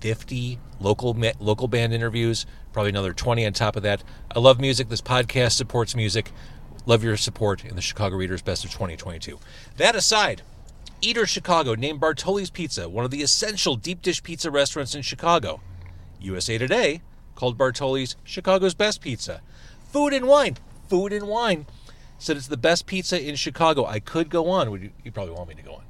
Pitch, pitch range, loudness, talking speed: 125 Hz, 105-165 Hz, -23 LUFS, 185 wpm